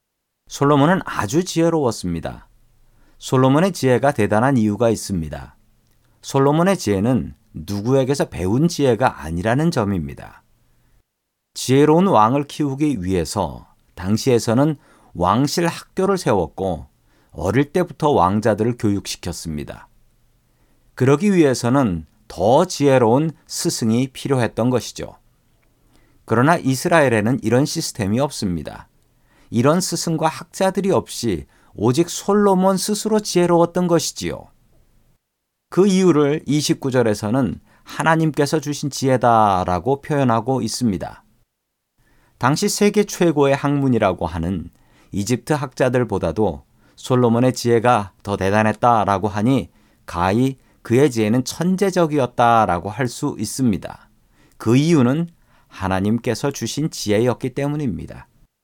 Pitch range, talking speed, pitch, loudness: 110-150 Hz, 280 characters per minute, 125 Hz, -18 LUFS